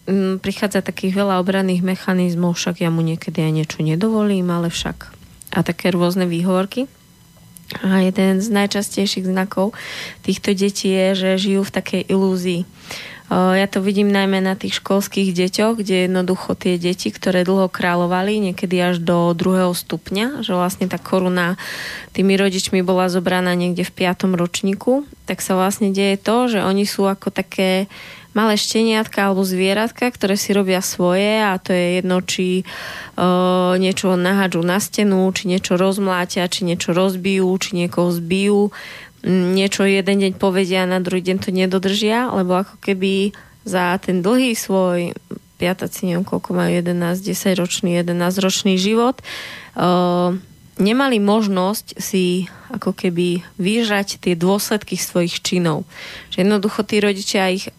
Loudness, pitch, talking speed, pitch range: -18 LUFS, 190 Hz, 150 wpm, 180-200 Hz